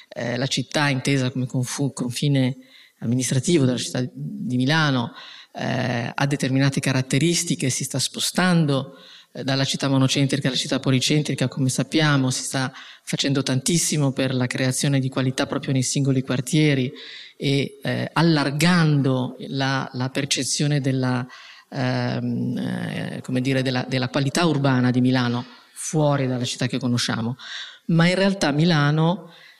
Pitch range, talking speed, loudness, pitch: 130-145 Hz, 135 wpm, -22 LUFS, 135 Hz